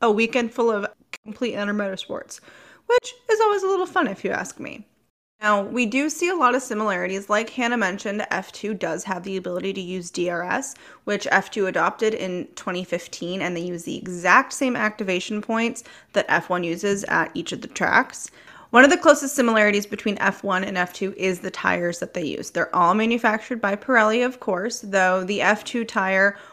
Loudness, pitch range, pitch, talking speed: -22 LUFS, 190-240 Hz, 210 Hz, 190 wpm